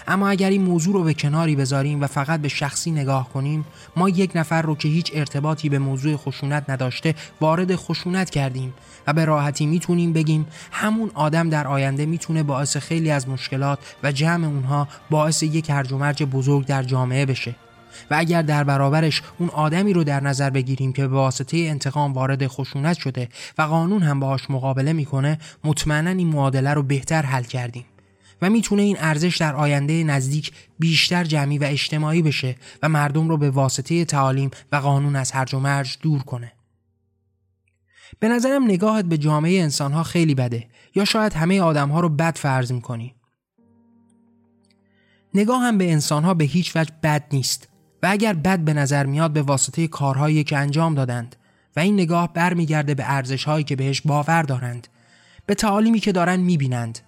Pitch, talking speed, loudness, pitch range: 150 Hz, 170 wpm, -21 LUFS, 135-165 Hz